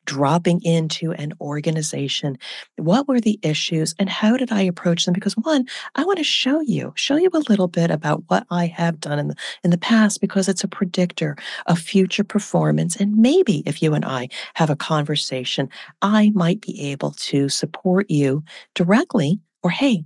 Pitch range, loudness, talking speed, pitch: 155-205 Hz, -20 LUFS, 185 wpm, 175 Hz